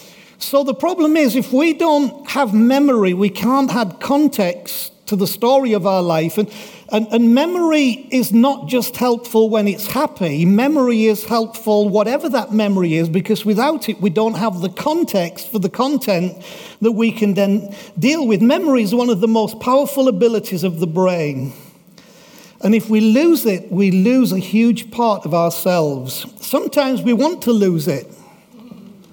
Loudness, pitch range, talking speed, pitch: -16 LUFS, 195-255 Hz, 170 wpm, 220 Hz